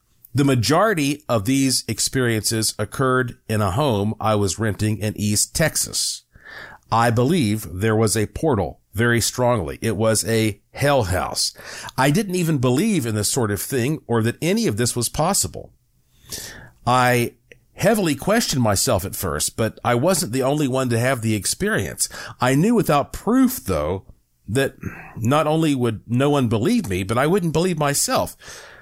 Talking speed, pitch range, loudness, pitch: 160 wpm, 110-140 Hz, -20 LUFS, 120 Hz